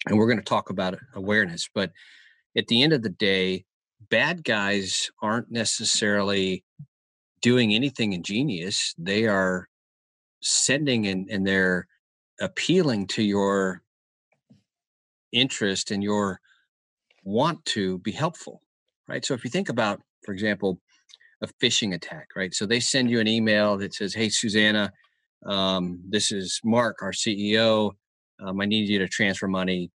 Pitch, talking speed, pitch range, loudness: 100 Hz, 145 wpm, 95-110 Hz, -24 LUFS